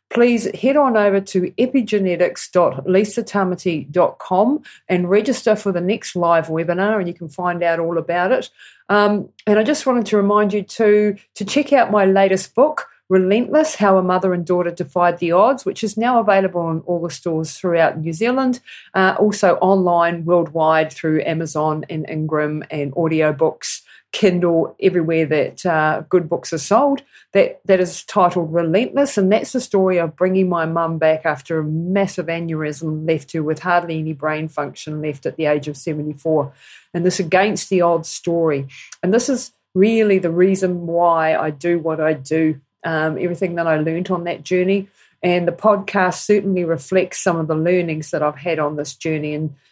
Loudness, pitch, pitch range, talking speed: -18 LUFS, 175 Hz, 160-195 Hz, 180 wpm